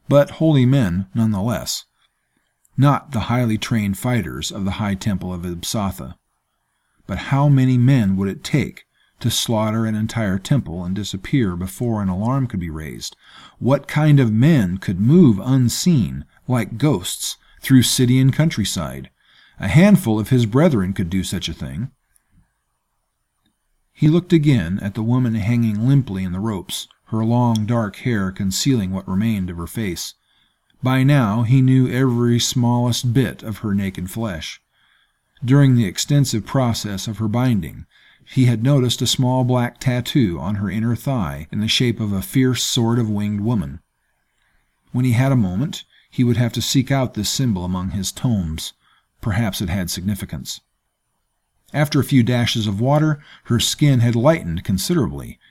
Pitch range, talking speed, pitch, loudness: 100-130 Hz, 165 wpm, 115 Hz, -19 LUFS